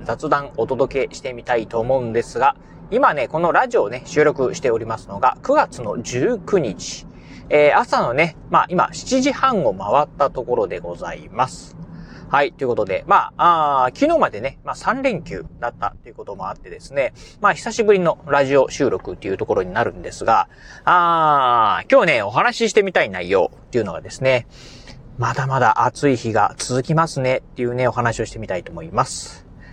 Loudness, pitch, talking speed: -19 LUFS, 140 Hz, 360 characters per minute